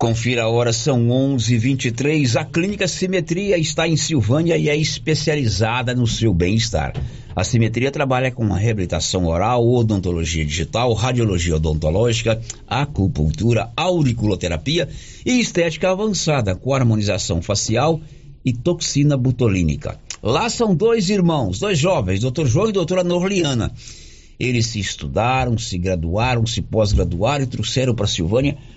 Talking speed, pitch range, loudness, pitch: 130 wpm, 105-150 Hz, -19 LUFS, 120 Hz